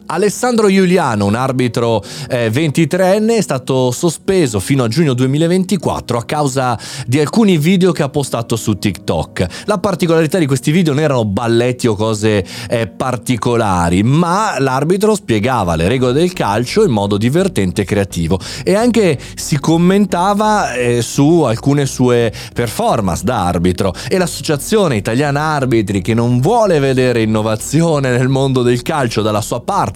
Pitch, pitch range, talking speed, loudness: 130 Hz, 115-170 Hz, 140 wpm, -14 LUFS